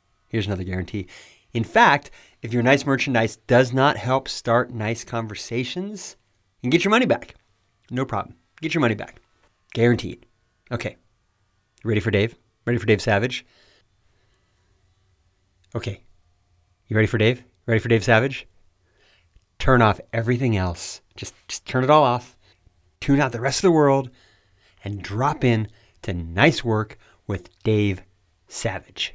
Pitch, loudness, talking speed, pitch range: 110 Hz, -22 LUFS, 145 wpm, 95-125 Hz